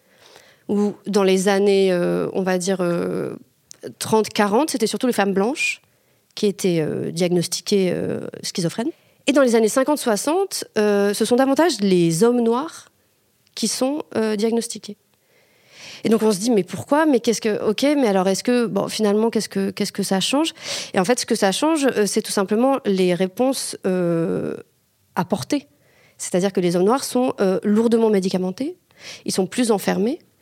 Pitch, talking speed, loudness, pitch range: 215 Hz, 170 wpm, -20 LUFS, 195-250 Hz